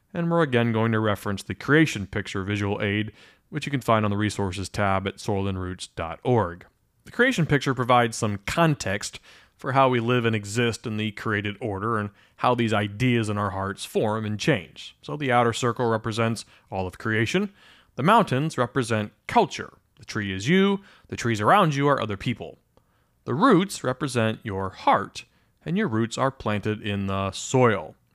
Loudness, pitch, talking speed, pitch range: -24 LUFS, 110 Hz, 175 wpm, 105-125 Hz